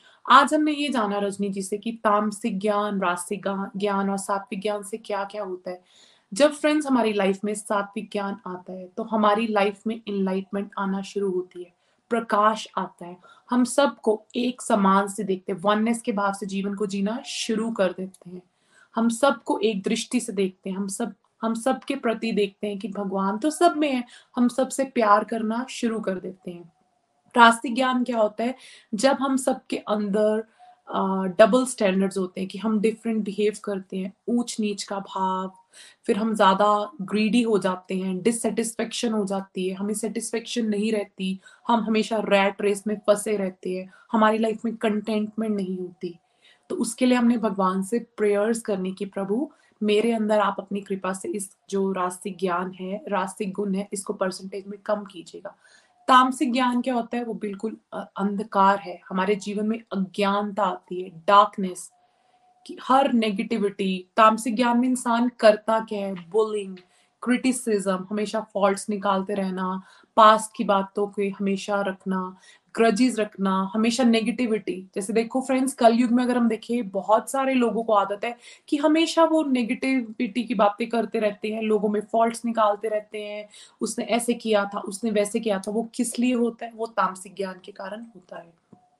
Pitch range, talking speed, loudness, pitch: 195-230 Hz, 175 wpm, -24 LUFS, 210 Hz